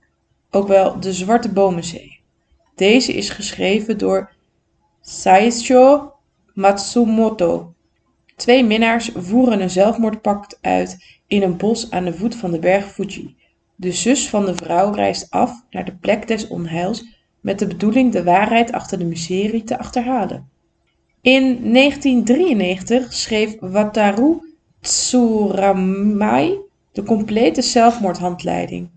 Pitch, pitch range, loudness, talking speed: 210 Hz, 185-240 Hz, -17 LUFS, 120 wpm